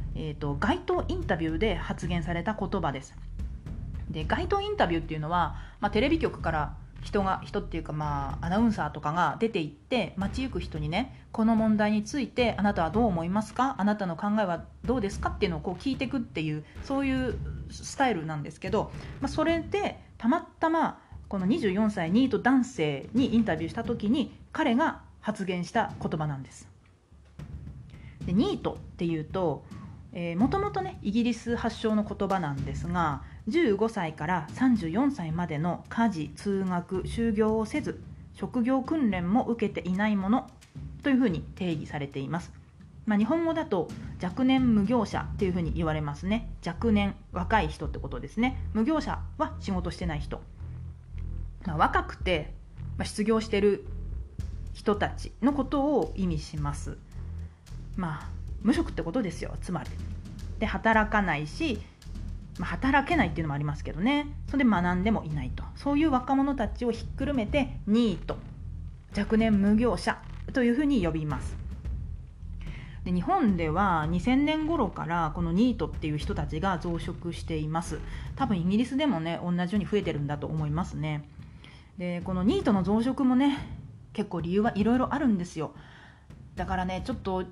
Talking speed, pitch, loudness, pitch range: 325 characters per minute, 195 Hz, -29 LUFS, 155-235 Hz